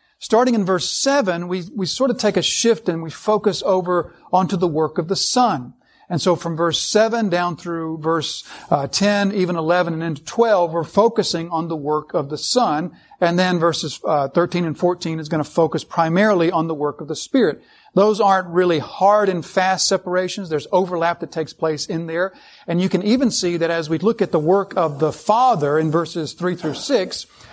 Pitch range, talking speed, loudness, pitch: 165-195 Hz, 210 wpm, -19 LUFS, 175 Hz